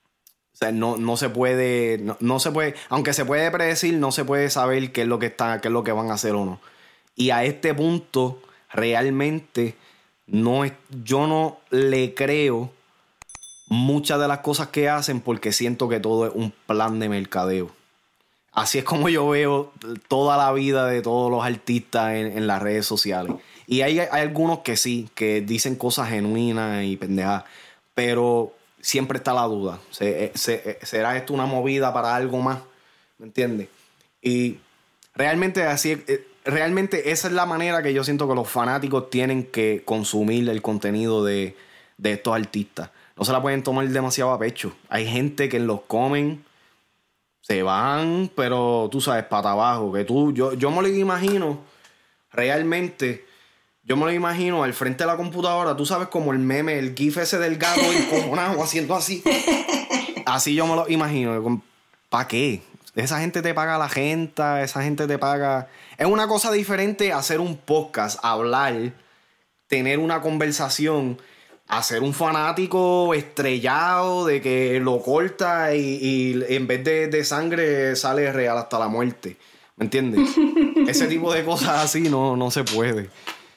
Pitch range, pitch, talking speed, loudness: 115-155 Hz, 135 Hz, 165 wpm, -22 LUFS